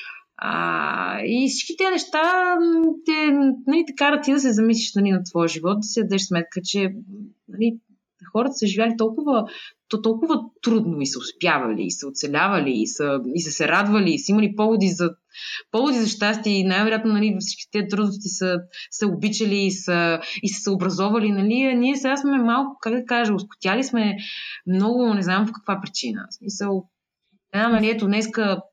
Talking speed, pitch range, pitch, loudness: 175 wpm, 195-240 Hz, 215 Hz, -21 LUFS